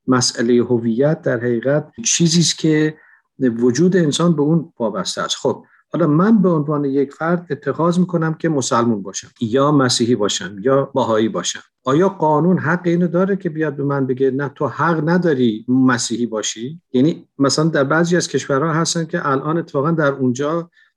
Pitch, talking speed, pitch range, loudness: 145 Hz, 170 wpm, 130-165 Hz, -17 LUFS